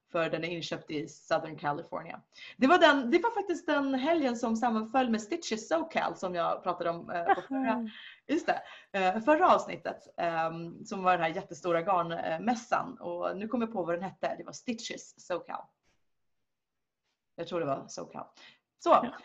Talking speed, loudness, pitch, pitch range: 170 wpm, -31 LUFS, 205 Hz, 170-265 Hz